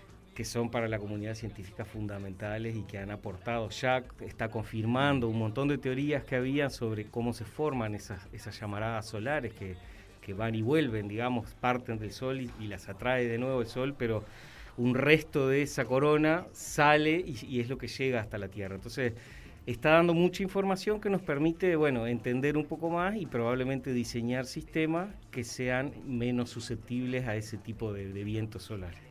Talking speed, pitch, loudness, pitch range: 185 wpm, 120 Hz, -32 LUFS, 110-140 Hz